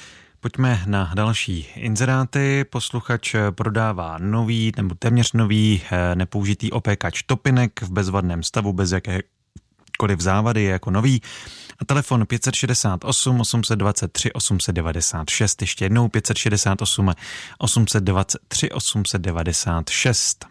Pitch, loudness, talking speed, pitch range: 105 Hz, -20 LUFS, 95 wpm, 95-120 Hz